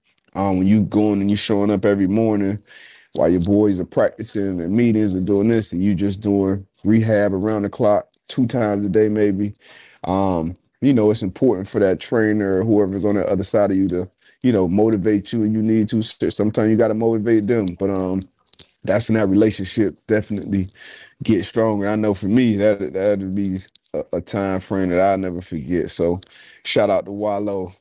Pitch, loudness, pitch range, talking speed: 100 Hz, -19 LUFS, 95-110 Hz, 205 wpm